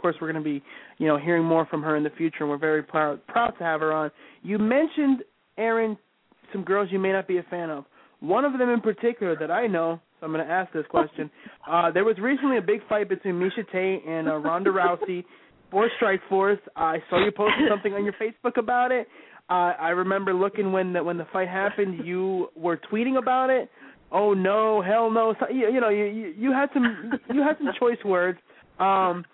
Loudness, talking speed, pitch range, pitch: -25 LUFS, 225 wpm, 170-225 Hz, 195 Hz